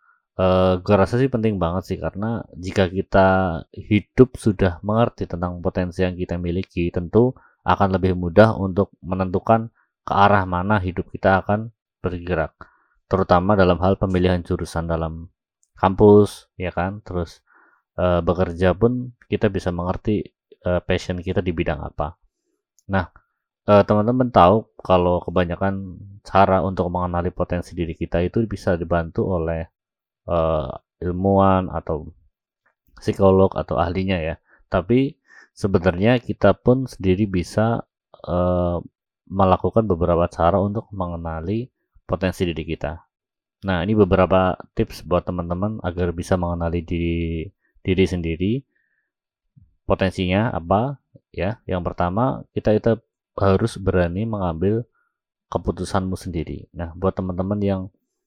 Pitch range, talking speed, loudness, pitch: 90-100 Hz, 125 wpm, -21 LUFS, 95 Hz